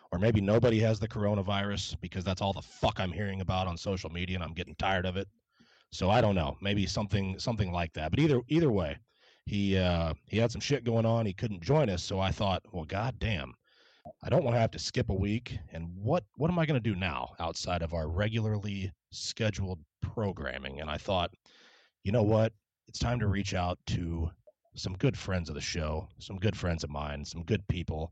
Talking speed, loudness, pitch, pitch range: 220 wpm, -32 LUFS, 100 Hz, 85-110 Hz